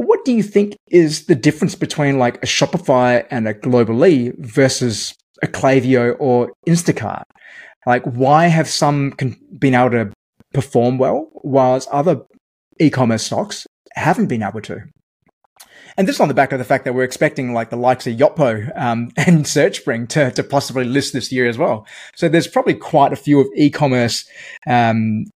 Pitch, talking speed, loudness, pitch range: 135 Hz, 175 wpm, -16 LUFS, 125-150 Hz